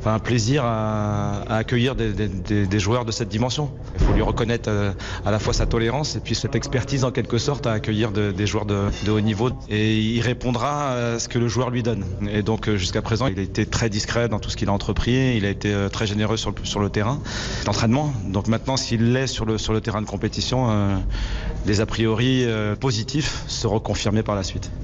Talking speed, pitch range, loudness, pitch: 235 wpm, 105-120 Hz, -23 LUFS, 110 Hz